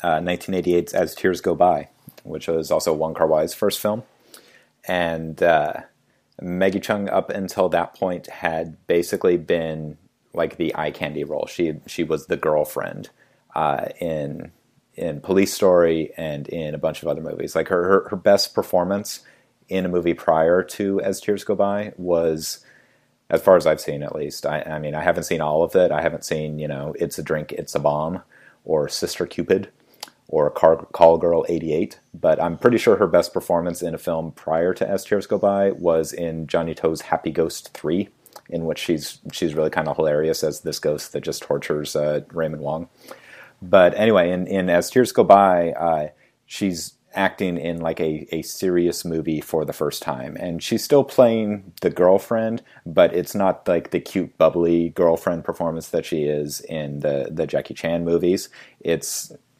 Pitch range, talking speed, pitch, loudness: 80-95 Hz, 185 wpm, 85 Hz, -21 LUFS